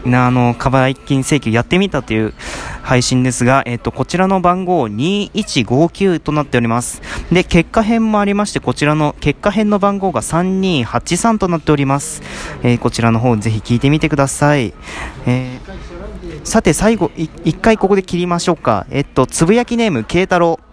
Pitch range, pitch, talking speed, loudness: 125-185 Hz, 150 Hz, 345 characters per minute, -15 LUFS